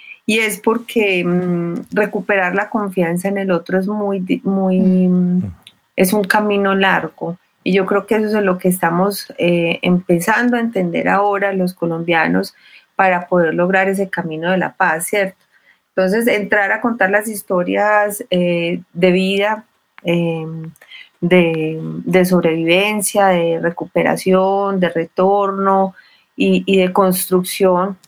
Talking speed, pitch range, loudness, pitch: 135 wpm, 175-200 Hz, -16 LUFS, 190 Hz